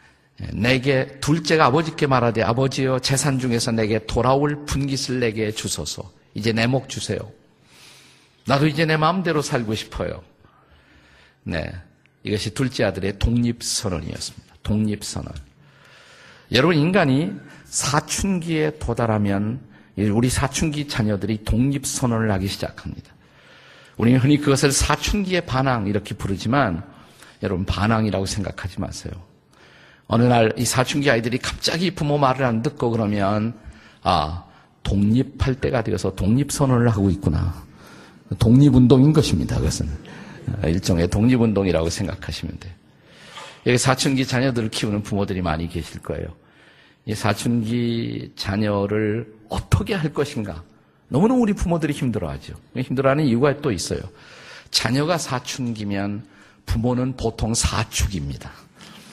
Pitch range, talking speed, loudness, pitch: 100-135 Hz, 305 characters per minute, -21 LUFS, 115 Hz